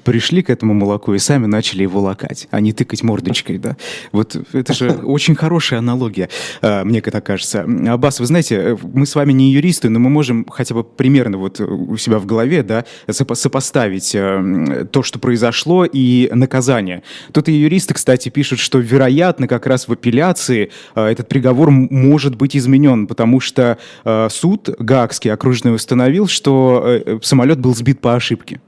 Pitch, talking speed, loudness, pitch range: 125 Hz, 165 wpm, -14 LUFS, 110-140 Hz